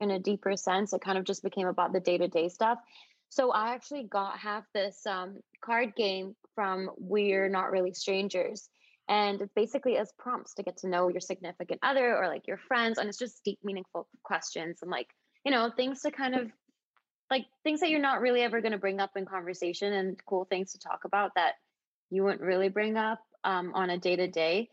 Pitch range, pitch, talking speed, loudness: 190-230 Hz, 200 Hz, 210 wpm, -31 LUFS